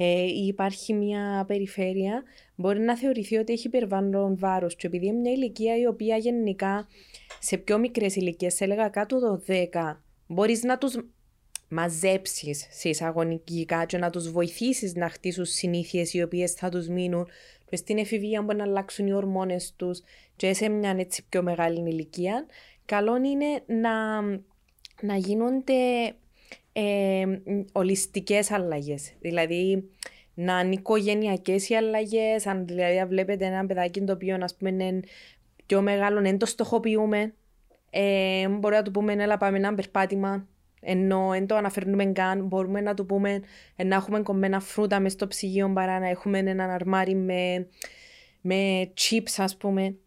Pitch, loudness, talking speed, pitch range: 195 Hz, -27 LUFS, 155 wpm, 185-210 Hz